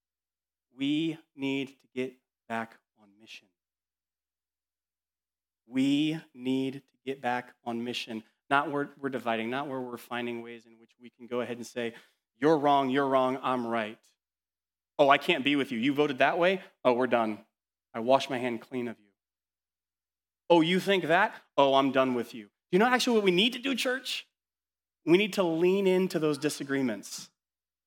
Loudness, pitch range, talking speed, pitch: -28 LUFS, 95-145 Hz, 180 wpm, 125 Hz